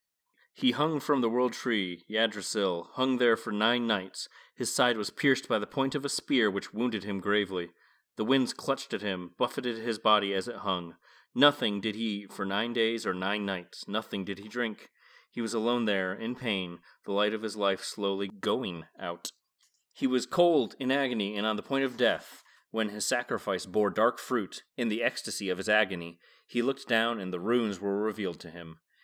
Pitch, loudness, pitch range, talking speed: 110 Hz, -30 LUFS, 100-120 Hz, 200 wpm